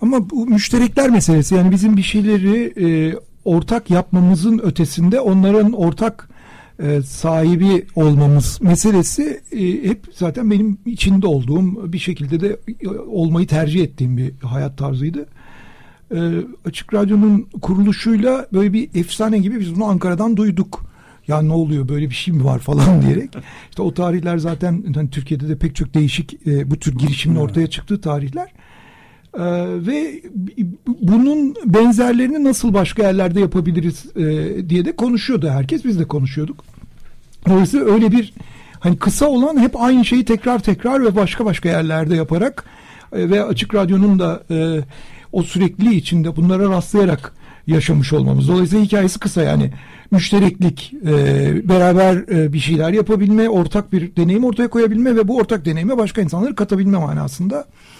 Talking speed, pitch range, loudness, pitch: 145 wpm, 160-215 Hz, -16 LUFS, 185 Hz